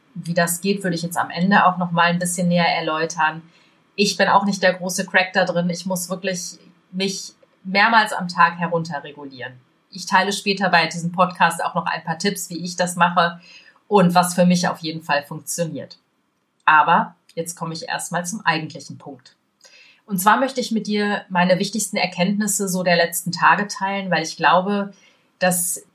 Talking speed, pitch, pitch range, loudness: 185 wpm, 180 Hz, 170-195 Hz, -19 LUFS